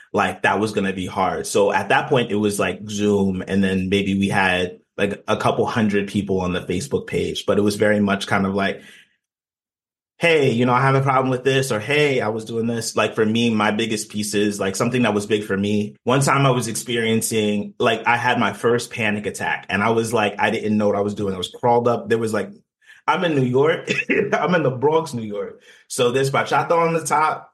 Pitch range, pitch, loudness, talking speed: 100-120 Hz, 105 Hz, -20 LUFS, 240 wpm